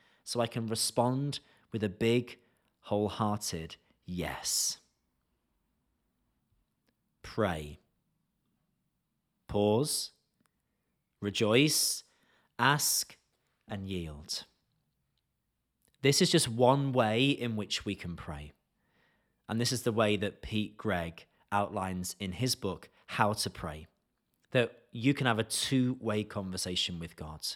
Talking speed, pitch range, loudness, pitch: 110 wpm, 90-120 Hz, -31 LUFS, 105 Hz